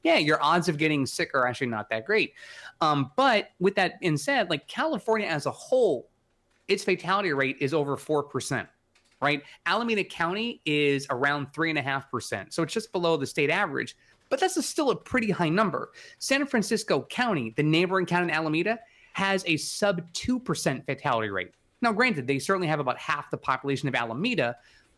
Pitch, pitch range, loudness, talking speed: 165 Hz, 140-210 Hz, -27 LUFS, 190 wpm